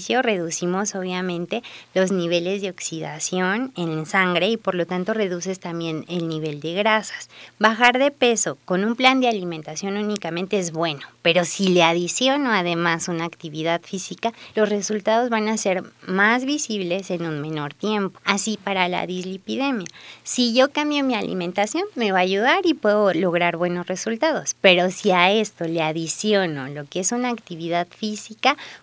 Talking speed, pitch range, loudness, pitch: 160 wpm, 175-220 Hz, -21 LUFS, 190 Hz